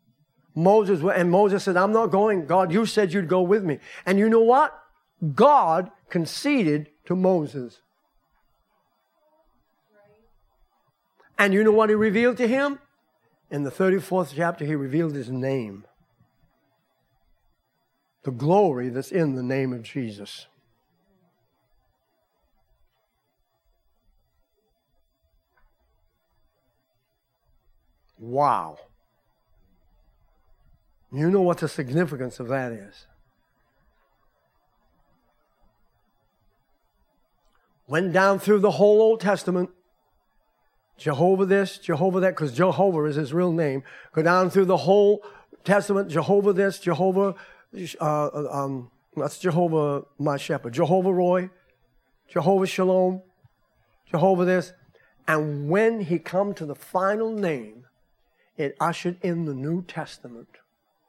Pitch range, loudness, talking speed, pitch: 145-195 Hz, -23 LUFS, 105 wpm, 175 Hz